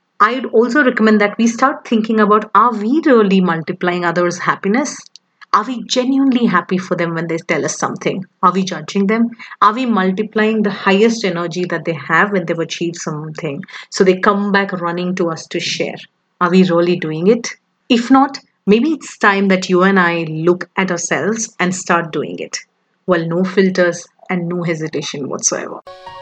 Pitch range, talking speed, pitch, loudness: 175-220 Hz, 185 wpm, 190 Hz, -15 LUFS